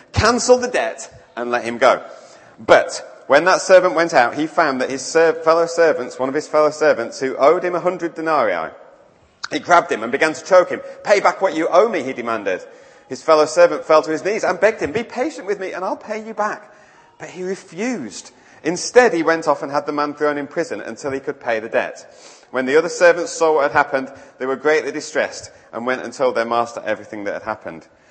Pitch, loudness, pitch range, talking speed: 165 Hz, -18 LUFS, 145-205 Hz, 230 wpm